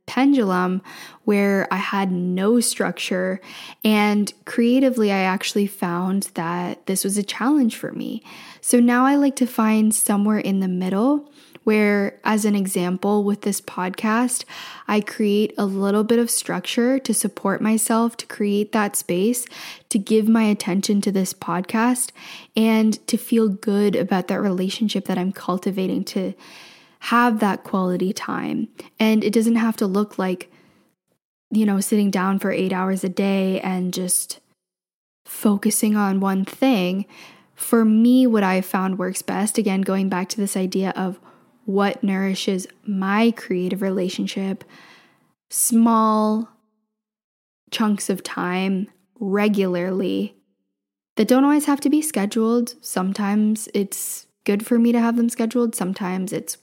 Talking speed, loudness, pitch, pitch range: 145 wpm, -21 LUFS, 205 Hz, 190-225 Hz